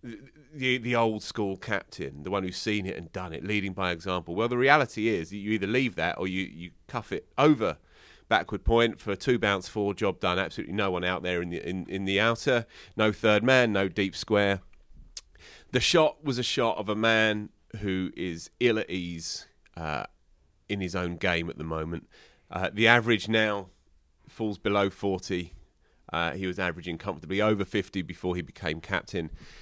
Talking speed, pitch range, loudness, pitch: 190 wpm, 90-110 Hz, -28 LUFS, 100 Hz